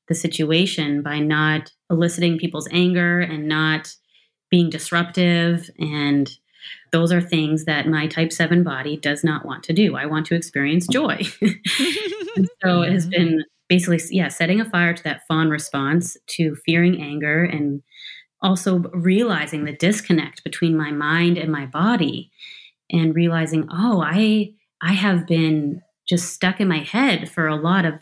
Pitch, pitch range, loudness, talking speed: 170 Hz, 155-180 Hz, -20 LUFS, 155 wpm